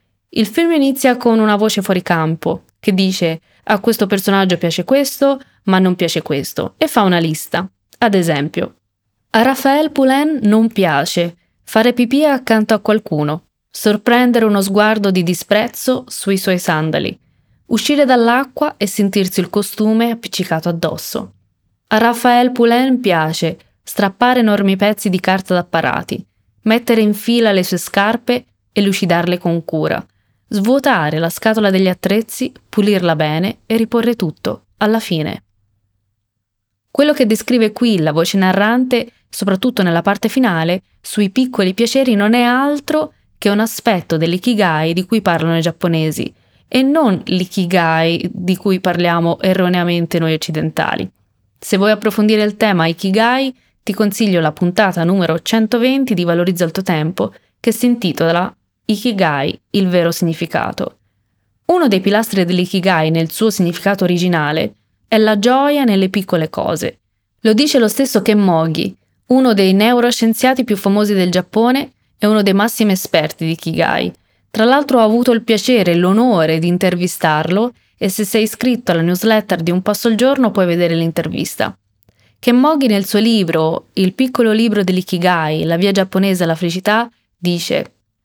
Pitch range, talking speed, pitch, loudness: 170-230 Hz, 145 wpm, 200 Hz, -15 LUFS